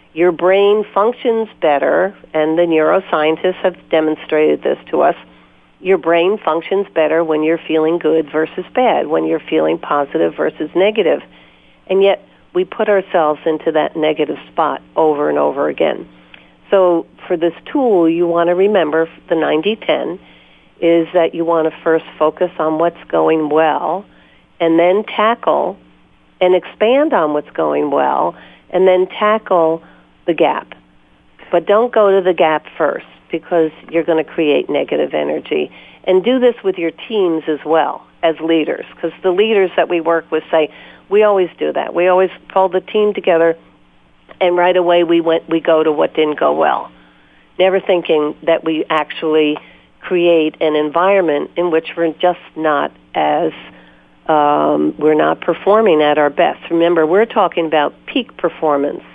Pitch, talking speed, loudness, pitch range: 165 Hz, 160 wpm, -15 LUFS, 150-185 Hz